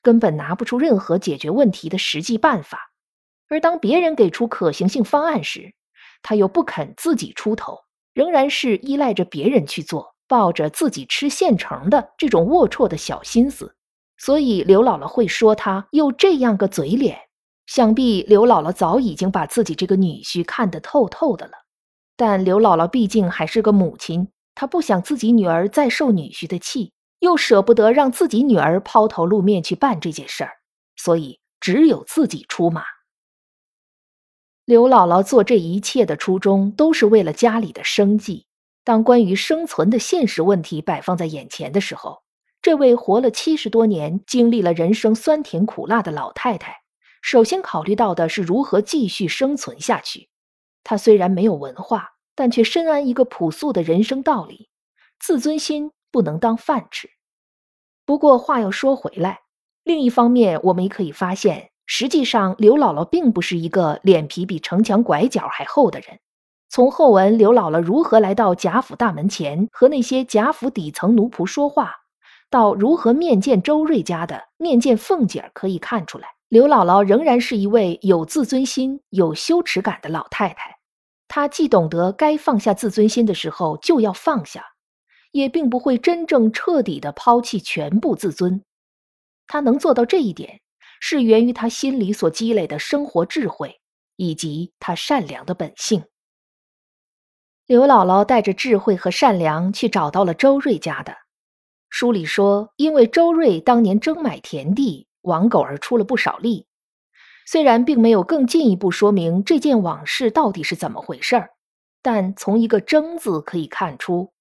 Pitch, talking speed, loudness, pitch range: 220 Hz, 255 characters per minute, -18 LUFS, 185-265 Hz